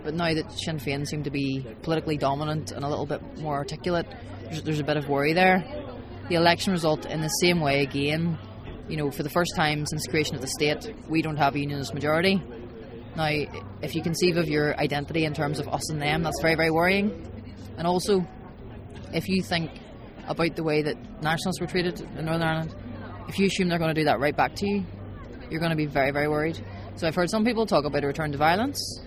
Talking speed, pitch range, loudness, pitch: 225 wpm, 135-165 Hz, -26 LUFS, 150 Hz